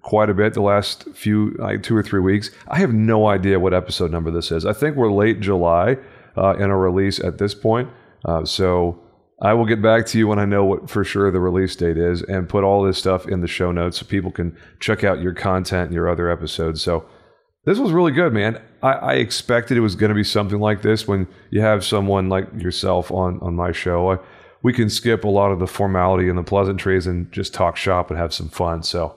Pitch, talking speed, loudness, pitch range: 100 Hz, 240 wpm, -19 LUFS, 90-105 Hz